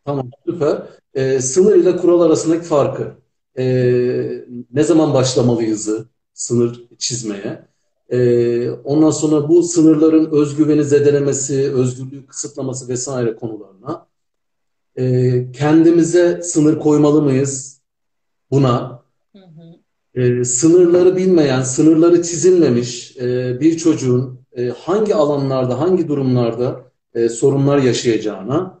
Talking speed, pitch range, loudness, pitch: 100 wpm, 125-160 Hz, -15 LUFS, 135 Hz